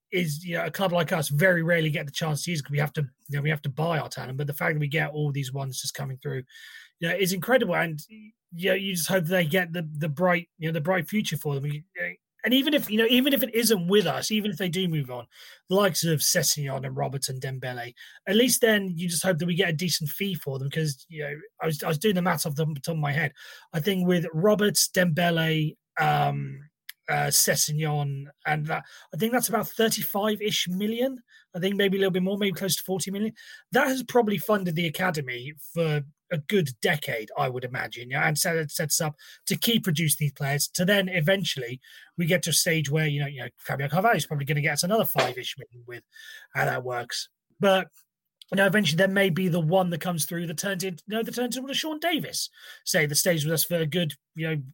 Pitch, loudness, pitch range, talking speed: 170 Hz, -26 LUFS, 150-195 Hz, 250 wpm